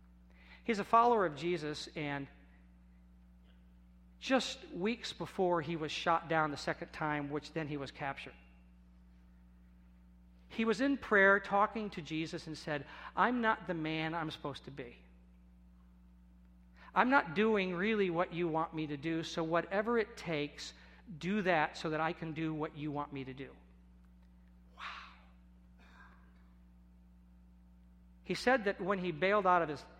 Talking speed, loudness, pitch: 150 wpm, -34 LUFS, 150 Hz